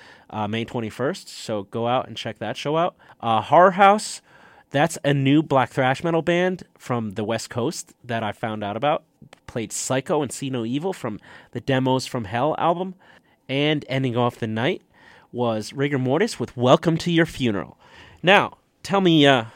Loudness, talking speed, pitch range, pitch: -22 LUFS, 180 wpm, 115-155 Hz, 130 Hz